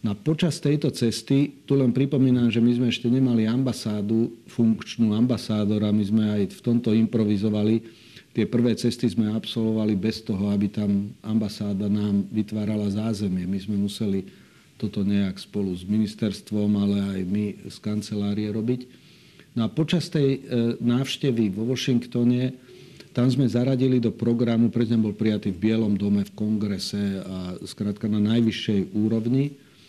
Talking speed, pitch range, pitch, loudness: 150 wpm, 105-120 Hz, 110 Hz, -24 LUFS